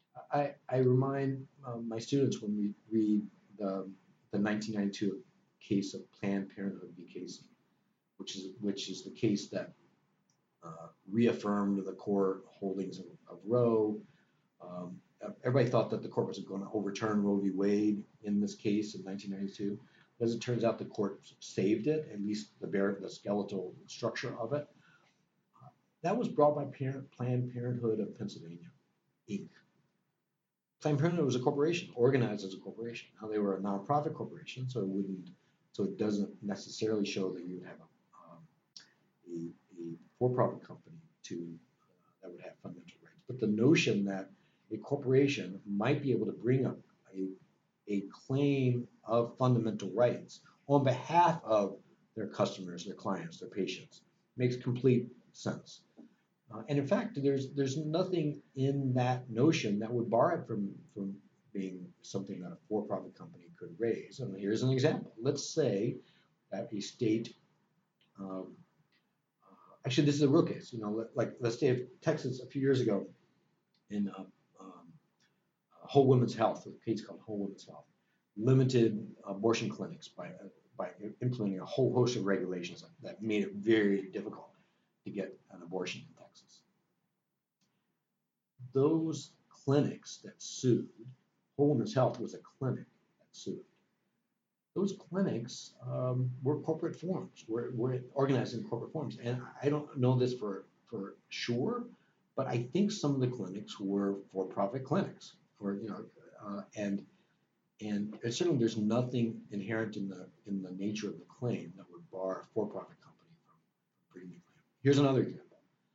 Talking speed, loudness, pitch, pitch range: 155 wpm, -34 LUFS, 115 Hz, 100-135 Hz